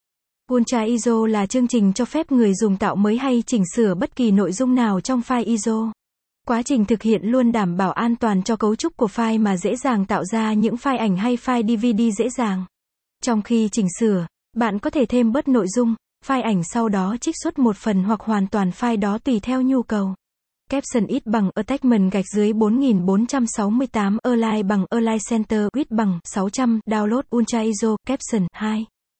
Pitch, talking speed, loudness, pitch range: 225 Hz, 195 wpm, -20 LUFS, 210-245 Hz